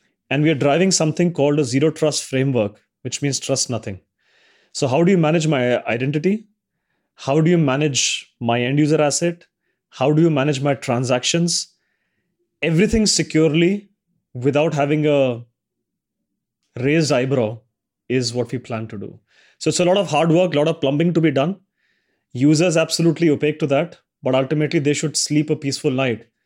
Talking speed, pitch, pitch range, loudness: 170 wpm, 150 Hz, 130-165 Hz, -19 LUFS